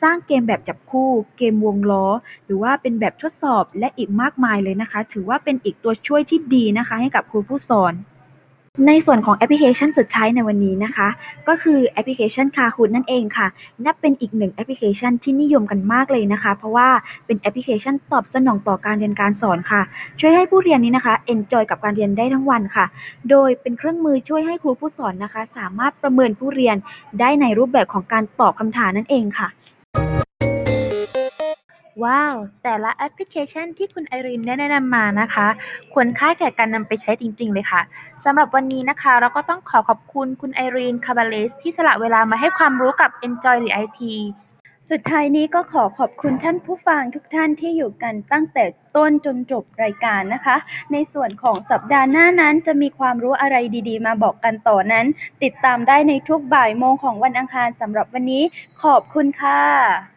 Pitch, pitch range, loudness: 250 Hz, 220-285 Hz, -18 LUFS